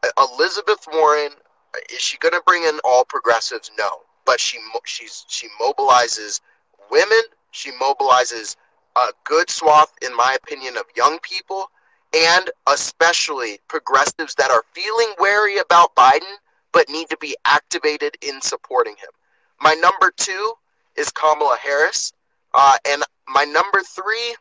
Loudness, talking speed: -17 LUFS, 140 wpm